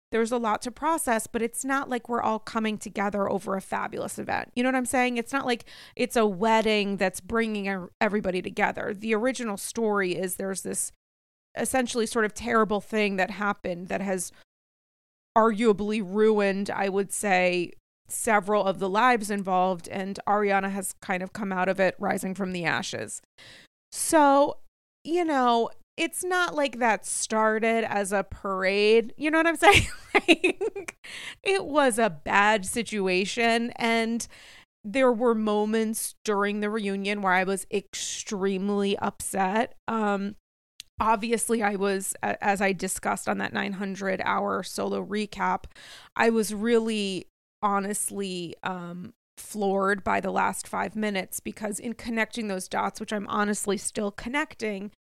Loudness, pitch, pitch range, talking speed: -26 LUFS, 210 Hz, 195-230 Hz, 150 wpm